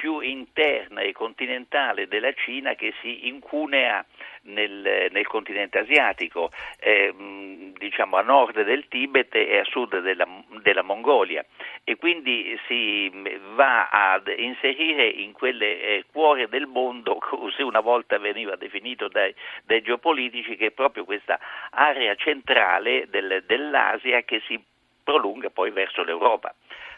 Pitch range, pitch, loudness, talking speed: 105-160 Hz, 125 Hz, -23 LUFS, 130 wpm